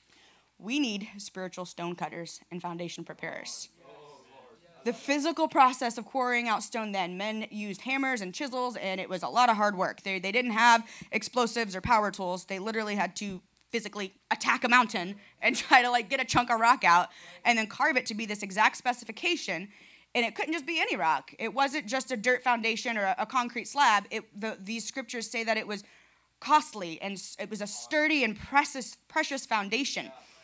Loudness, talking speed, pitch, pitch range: -28 LUFS, 195 wpm, 225 Hz, 195-250 Hz